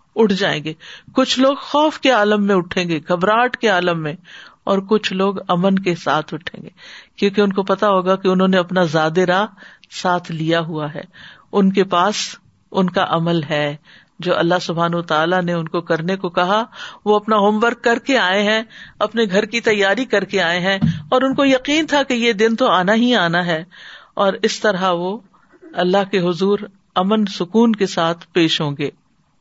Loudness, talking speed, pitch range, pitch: -17 LUFS, 200 wpm, 175-215 Hz, 195 Hz